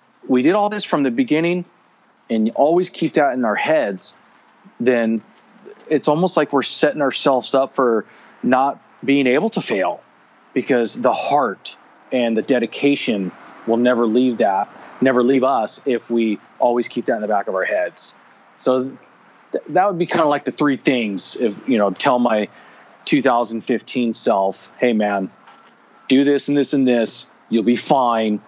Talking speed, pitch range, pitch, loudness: 170 wpm, 115-140 Hz, 130 Hz, -18 LUFS